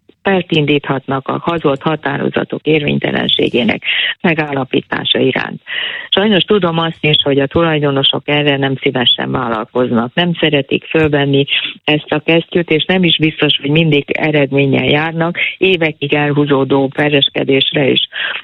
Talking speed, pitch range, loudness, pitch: 115 wpm, 140-165 Hz, -13 LUFS, 150 Hz